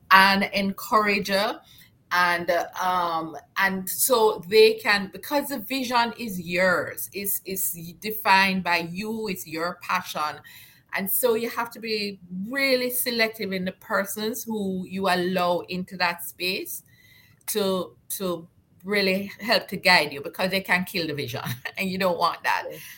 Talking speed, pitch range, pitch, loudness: 145 wpm, 180-215 Hz, 190 Hz, -24 LUFS